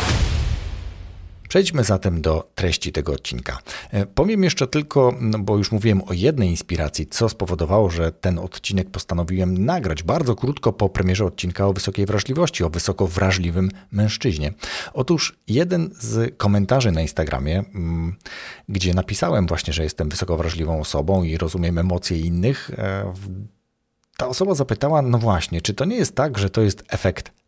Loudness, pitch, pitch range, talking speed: -21 LUFS, 95 Hz, 85-110 Hz, 145 wpm